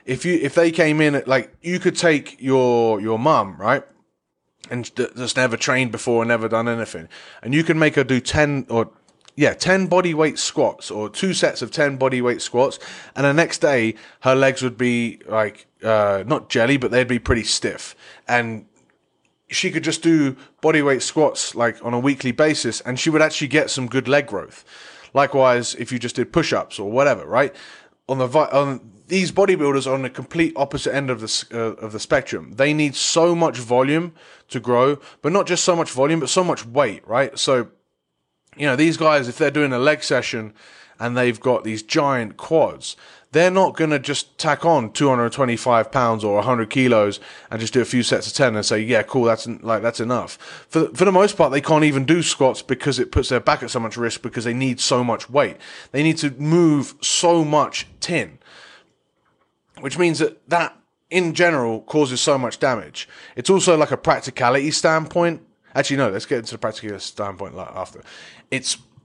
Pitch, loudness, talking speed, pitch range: 135 Hz, -19 LUFS, 205 wpm, 120-155 Hz